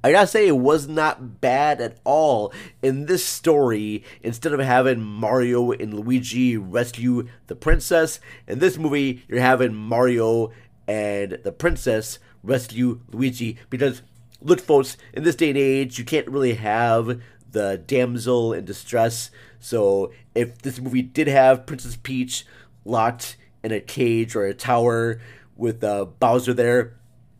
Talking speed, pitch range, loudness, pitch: 145 wpm, 115-130 Hz, -21 LUFS, 125 Hz